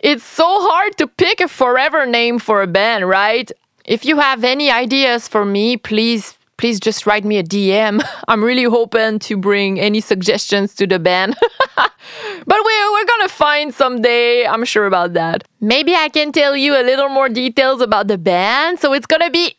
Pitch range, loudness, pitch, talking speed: 210-295 Hz, -14 LUFS, 240 Hz, 190 wpm